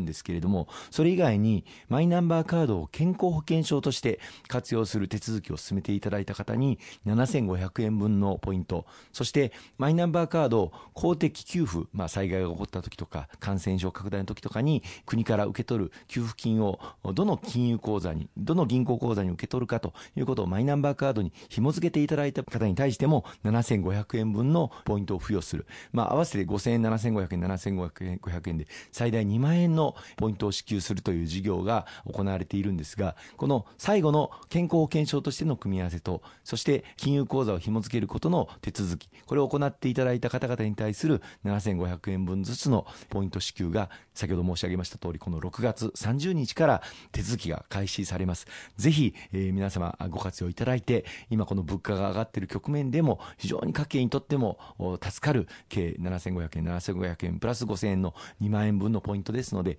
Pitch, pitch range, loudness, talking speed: 105 Hz, 95-130 Hz, -29 LUFS, 365 characters per minute